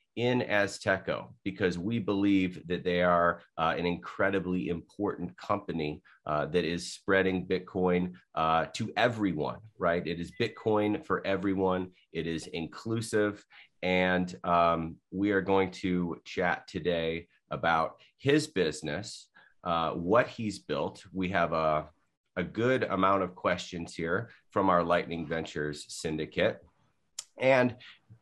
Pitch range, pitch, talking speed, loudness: 85-100 Hz, 90 Hz, 130 wpm, -30 LUFS